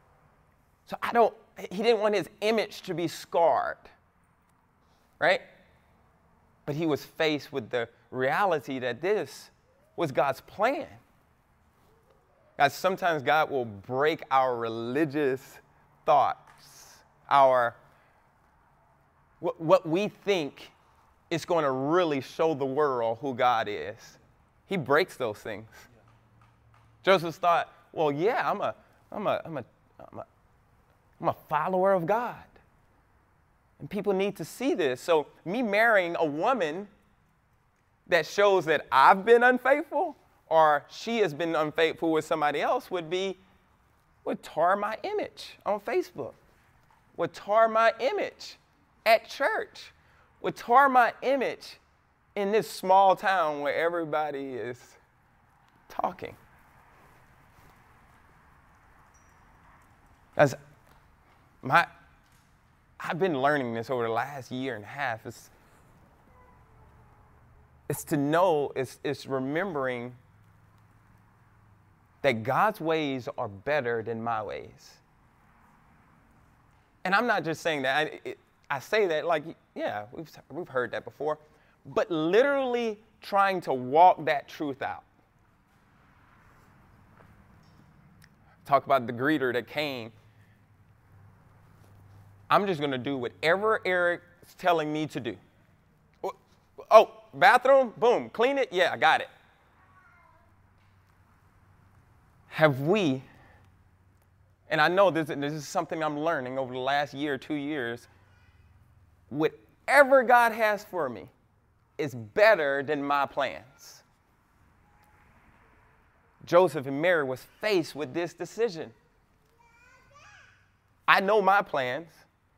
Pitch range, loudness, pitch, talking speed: 115-185 Hz, -27 LUFS, 145 Hz, 115 wpm